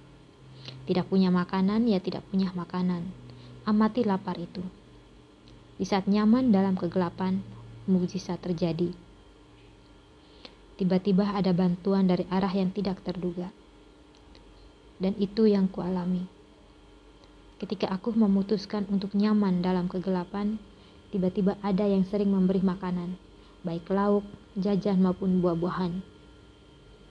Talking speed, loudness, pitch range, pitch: 105 wpm, -27 LUFS, 180-200 Hz, 185 Hz